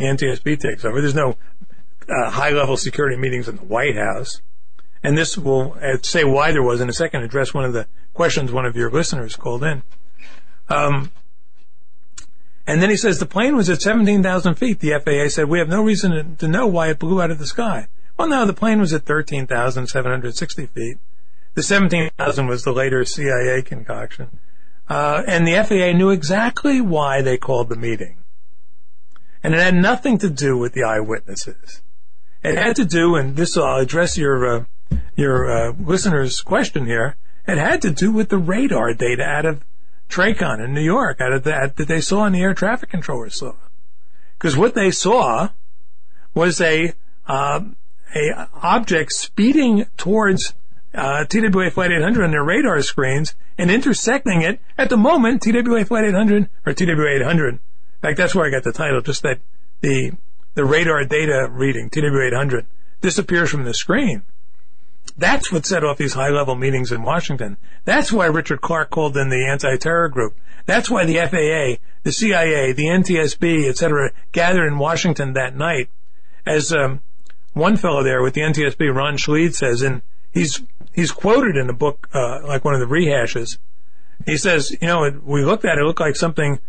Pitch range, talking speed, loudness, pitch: 135-180 Hz, 180 wpm, -18 LUFS, 155 Hz